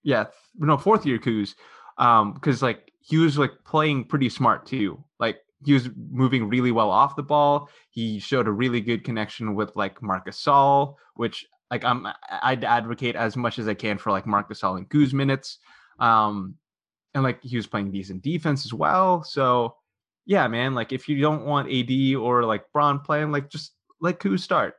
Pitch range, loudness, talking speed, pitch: 110-145 Hz, -23 LUFS, 190 wpm, 130 Hz